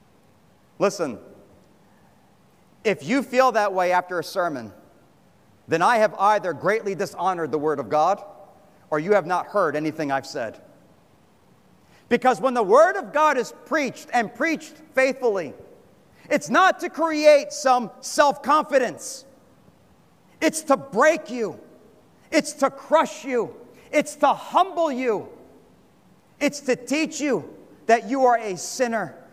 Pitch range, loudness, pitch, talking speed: 205-295 Hz, -22 LUFS, 255 Hz, 135 wpm